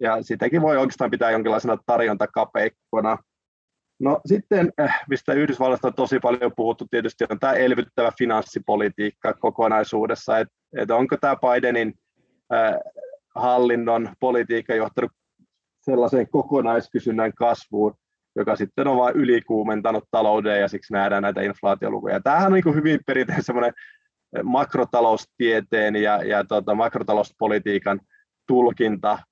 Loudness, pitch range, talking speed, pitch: -22 LUFS, 105-130 Hz, 115 wpm, 120 Hz